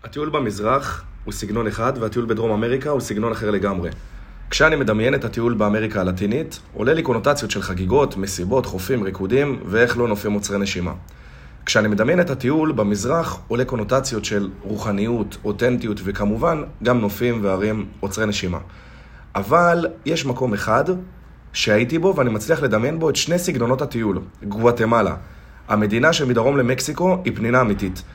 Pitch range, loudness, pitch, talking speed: 100-130 Hz, -20 LUFS, 110 Hz, 145 wpm